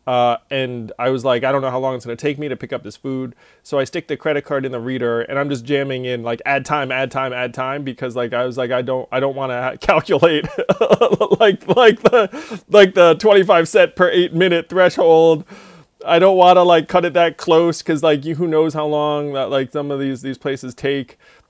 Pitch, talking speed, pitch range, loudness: 140 Hz, 245 wpm, 130-165 Hz, -16 LUFS